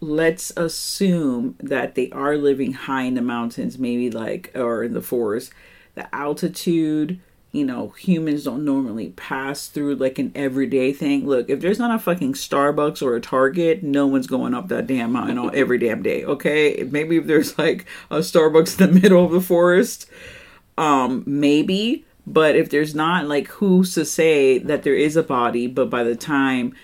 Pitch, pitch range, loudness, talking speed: 155 Hz, 140-190 Hz, -20 LUFS, 185 wpm